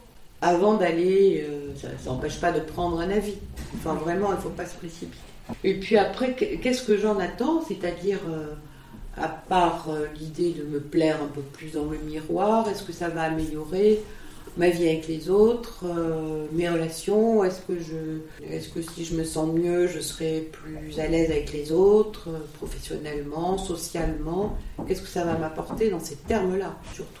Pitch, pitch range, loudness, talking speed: 170 Hz, 155-190 Hz, -26 LUFS, 180 wpm